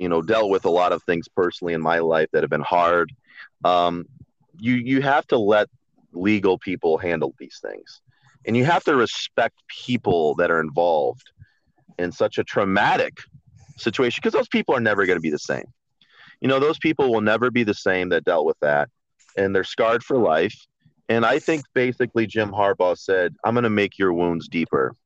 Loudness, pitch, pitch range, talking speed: -21 LUFS, 105 Hz, 85-125 Hz, 195 wpm